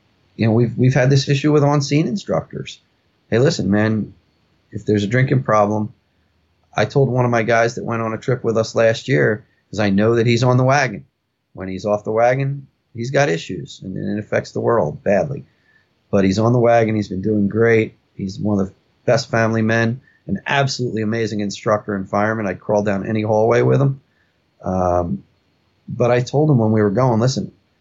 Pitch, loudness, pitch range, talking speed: 110 Hz, -18 LUFS, 105-125 Hz, 205 wpm